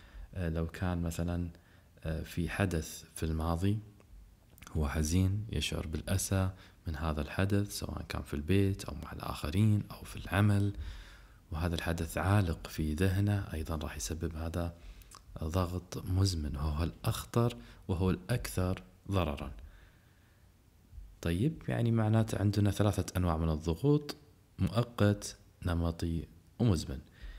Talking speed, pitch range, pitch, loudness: 110 wpm, 80-100 Hz, 90 Hz, -34 LUFS